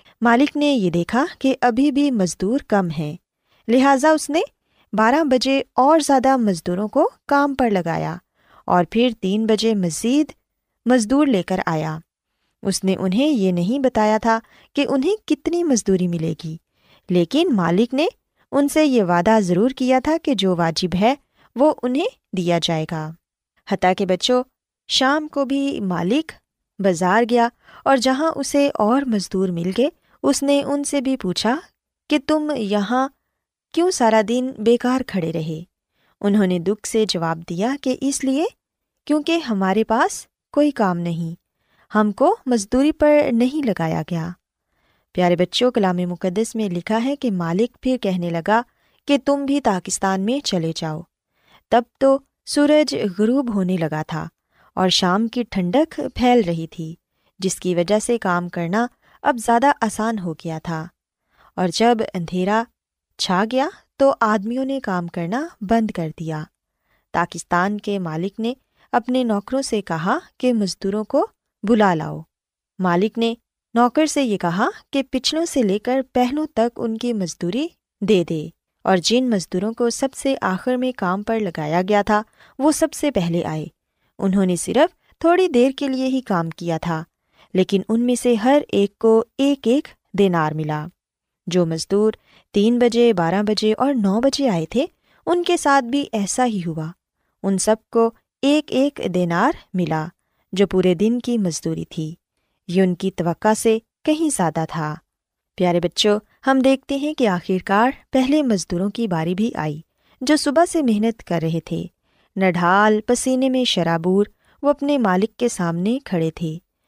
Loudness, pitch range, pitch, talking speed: -20 LUFS, 180-265 Hz, 220 Hz, 160 wpm